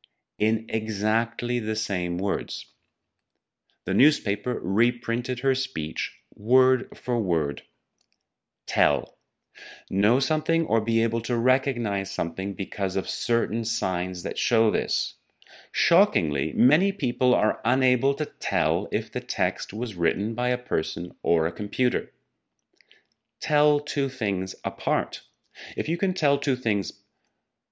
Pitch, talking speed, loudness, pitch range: 115 Hz, 125 wpm, -25 LUFS, 100-130 Hz